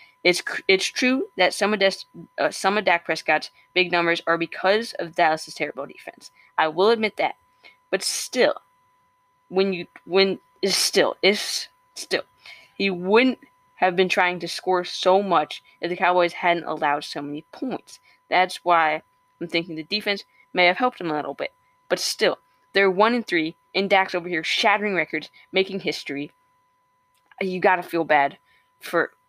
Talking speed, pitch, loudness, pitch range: 170 wpm, 190 Hz, -22 LUFS, 170-225 Hz